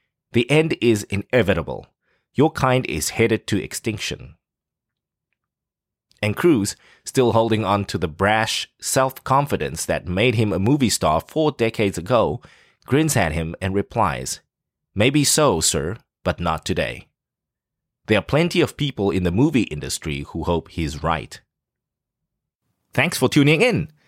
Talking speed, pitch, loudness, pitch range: 140 wpm, 110 Hz, -20 LUFS, 90-130 Hz